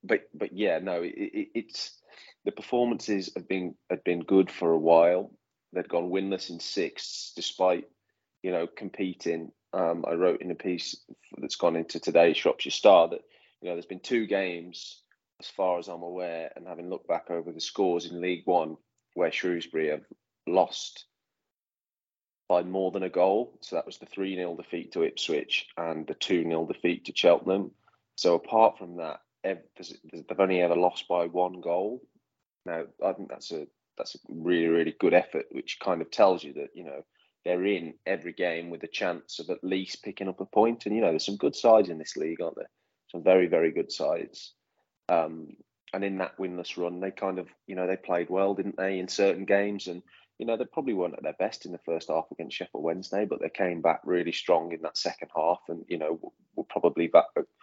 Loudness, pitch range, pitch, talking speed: -28 LUFS, 85-95 Hz, 90 Hz, 205 wpm